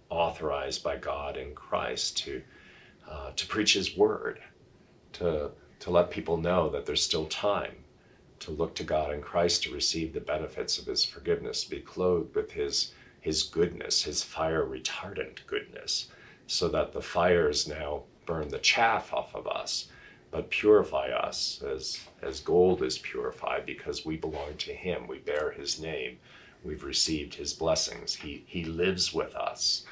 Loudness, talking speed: -30 LUFS, 160 wpm